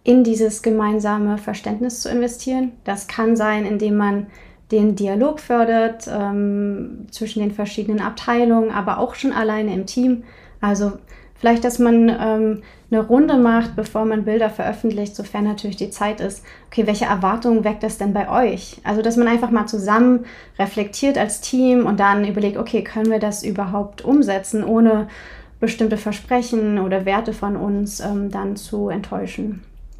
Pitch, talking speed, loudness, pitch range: 215 Hz, 160 wpm, -19 LUFS, 205-230 Hz